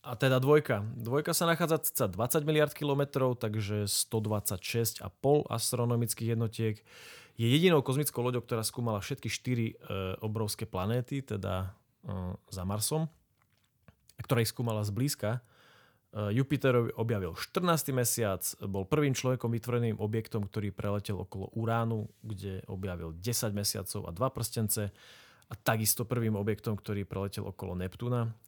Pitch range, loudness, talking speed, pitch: 105-125 Hz, -32 LUFS, 135 wpm, 115 Hz